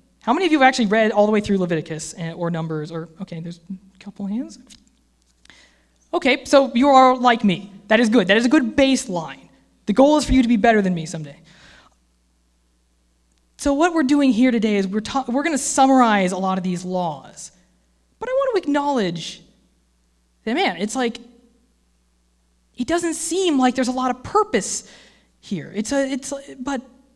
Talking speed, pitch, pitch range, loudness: 190 wpm, 215 Hz, 165-265 Hz, -19 LUFS